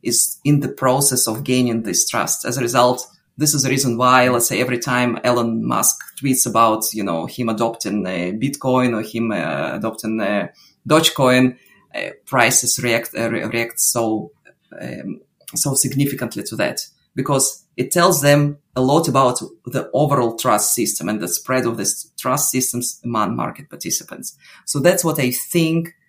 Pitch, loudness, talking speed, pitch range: 125 Hz, -18 LUFS, 170 wpm, 115-140 Hz